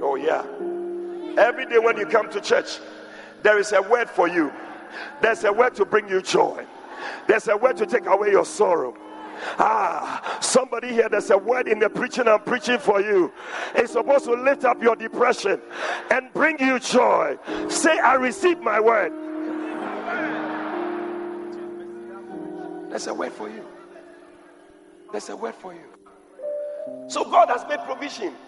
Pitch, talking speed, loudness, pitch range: 310 Hz, 155 wpm, -22 LUFS, 240-345 Hz